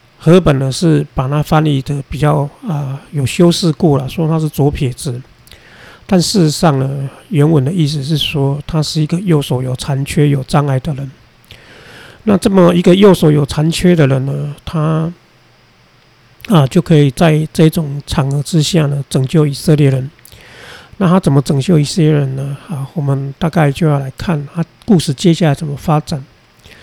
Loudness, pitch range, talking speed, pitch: -13 LUFS, 140-165 Hz, 250 characters per minute, 150 Hz